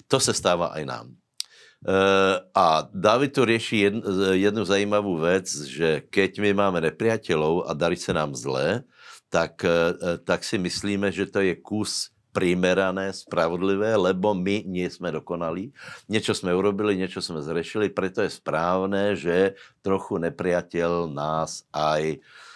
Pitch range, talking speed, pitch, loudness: 85-100 Hz, 135 wpm, 95 Hz, -24 LUFS